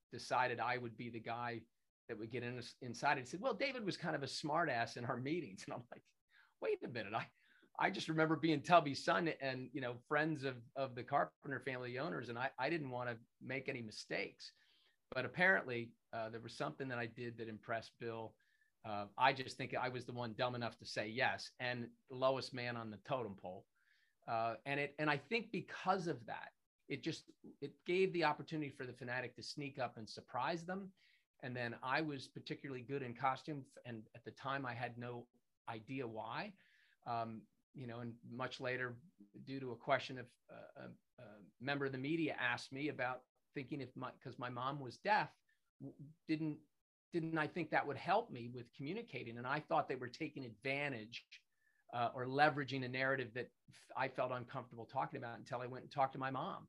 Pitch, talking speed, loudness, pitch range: 130 Hz, 205 wpm, -42 LUFS, 120-150 Hz